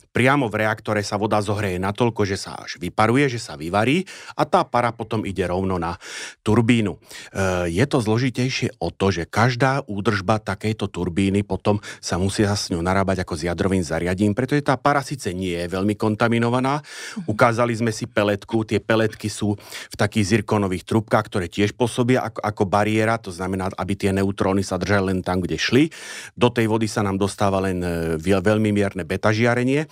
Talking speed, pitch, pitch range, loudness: 180 wpm, 105 Hz, 95-115 Hz, -21 LUFS